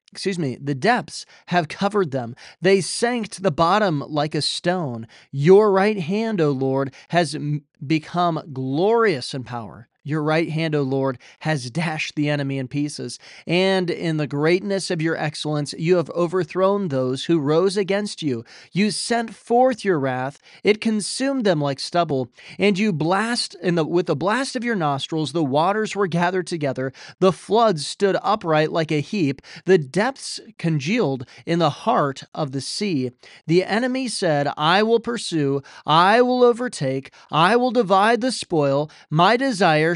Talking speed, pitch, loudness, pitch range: 165 wpm, 170 Hz, -21 LUFS, 145-200 Hz